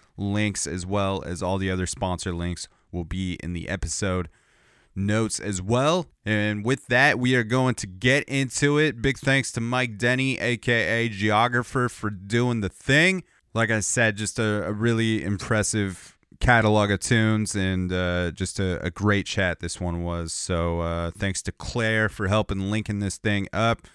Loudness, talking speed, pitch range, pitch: -24 LUFS, 175 wpm, 95-120 Hz, 105 Hz